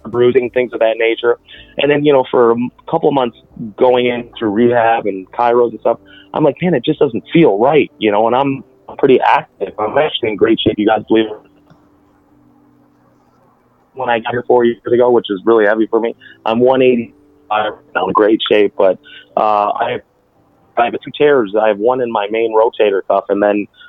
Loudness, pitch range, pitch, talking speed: -14 LUFS, 110-130 Hz, 120 Hz, 205 wpm